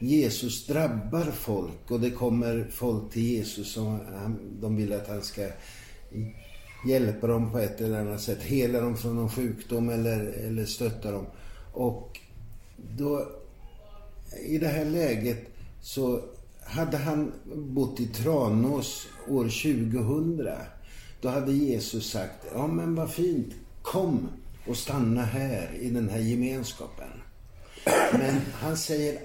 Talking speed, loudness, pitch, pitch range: 135 wpm, -29 LUFS, 115 Hz, 105-135 Hz